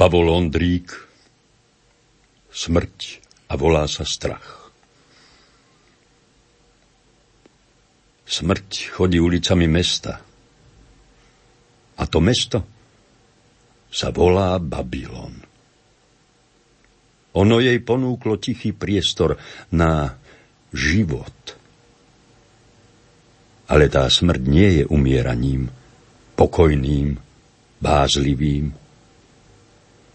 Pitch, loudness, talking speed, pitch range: 90 Hz, -19 LUFS, 65 wpm, 75-120 Hz